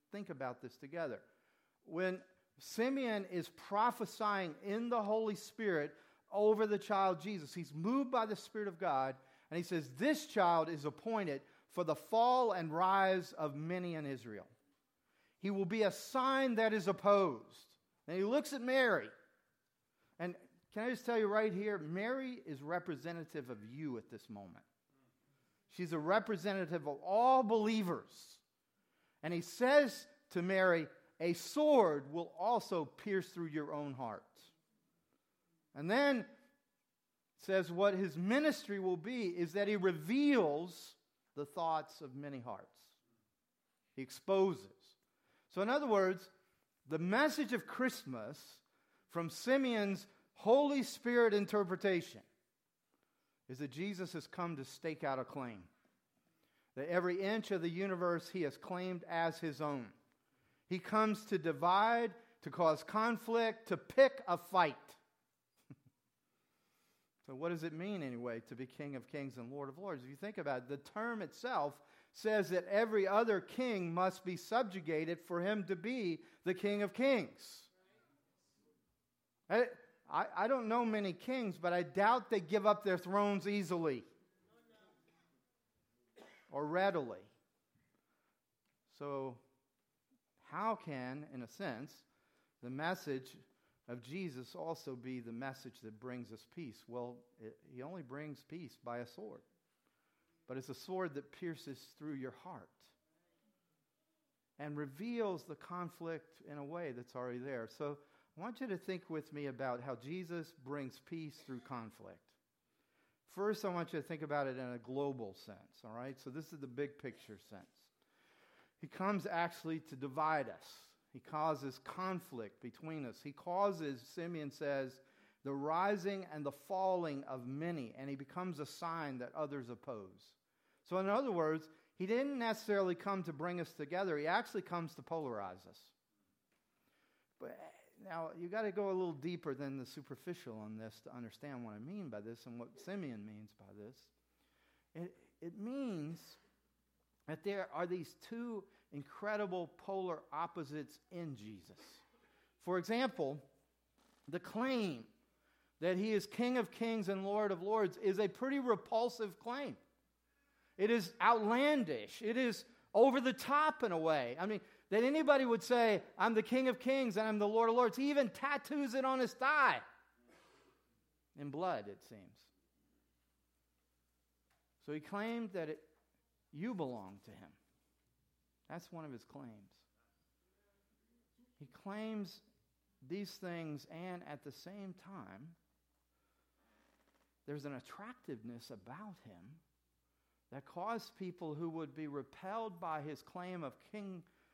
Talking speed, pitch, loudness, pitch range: 145 wpm, 175 Hz, -39 LUFS, 140-210 Hz